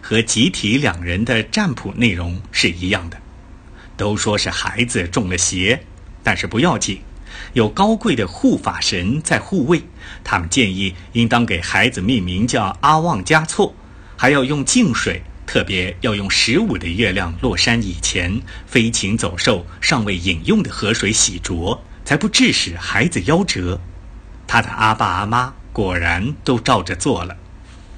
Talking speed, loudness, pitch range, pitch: 225 characters per minute, -17 LUFS, 90-120 Hz, 100 Hz